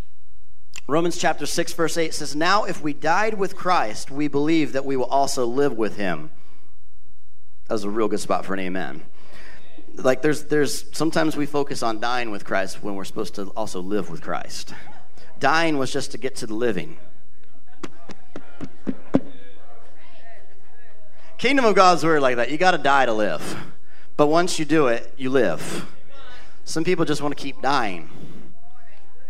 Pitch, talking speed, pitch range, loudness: 140 Hz, 170 wpm, 100-160 Hz, -23 LUFS